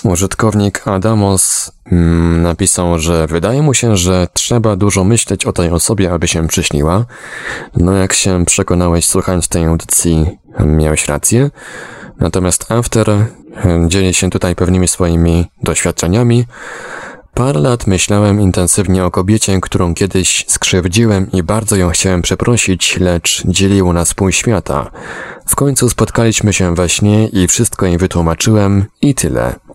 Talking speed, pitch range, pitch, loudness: 130 wpm, 85-105 Hz, 95 Hz, -12 LUFS